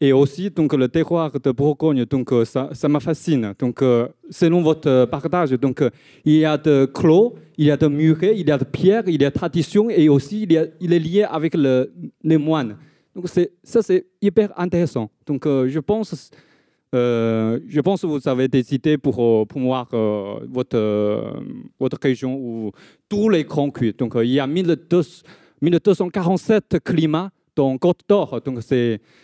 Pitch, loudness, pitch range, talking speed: 150 Hz, -19 LUFS, 130-175 Hz, 185 wpm